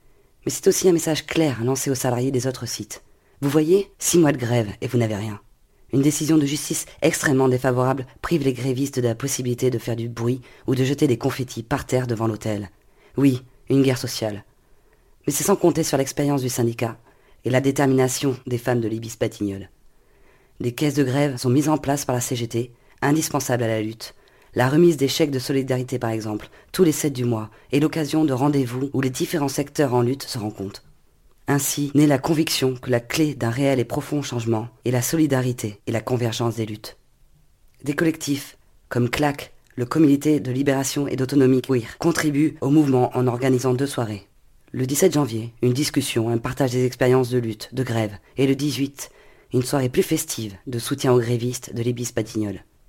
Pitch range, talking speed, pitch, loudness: 120-145 Hz, 195 wpm, 130 Hz, -22 LUFS